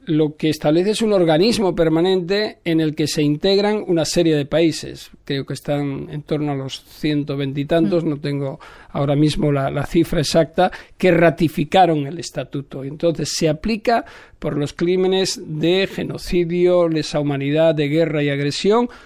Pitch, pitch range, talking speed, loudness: 160 Hz, 145-175 Hz, 160 wpm, -19 LUFS